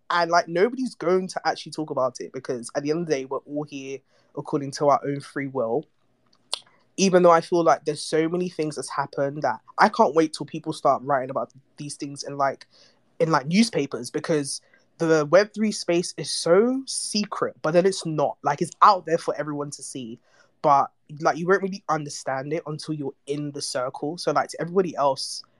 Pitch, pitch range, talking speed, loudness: 155 Hz, 140-175 Hz, 205 wpm, -24 LUFS